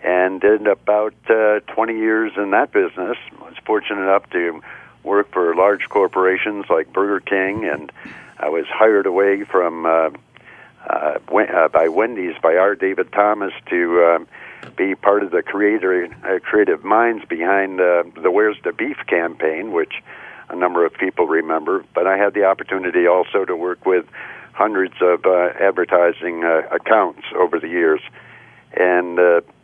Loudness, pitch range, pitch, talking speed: -17 LUFS, 85-105 Hz, 95 Hz, 160 wpm